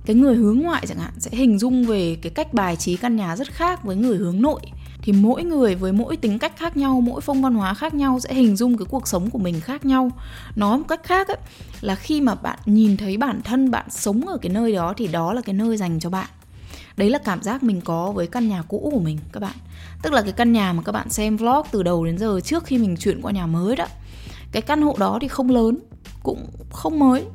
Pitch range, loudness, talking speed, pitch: 190-260 Hz, -21 LUFS, 265 wpm, 220 Hz